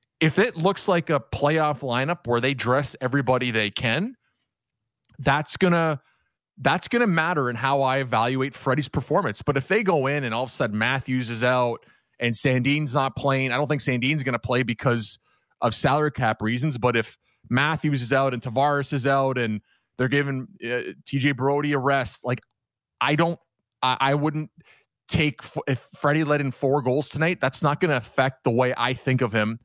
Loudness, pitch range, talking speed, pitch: -23 LUFS, 125-145 Hz, 190 wpm, 135 Hz